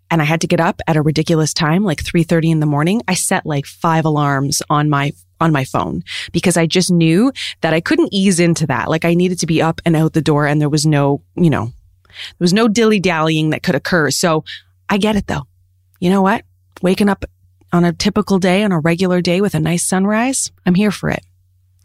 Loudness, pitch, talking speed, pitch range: -15 LUFS, 165 Hz, 235 wpm, 145-185 Hz